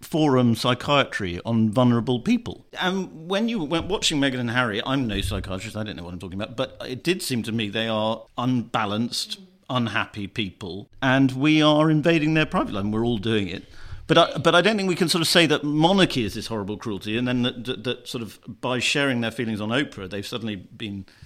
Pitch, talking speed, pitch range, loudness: 125 Hz, 225 wpm, 110-150 Hz, -23 LUFS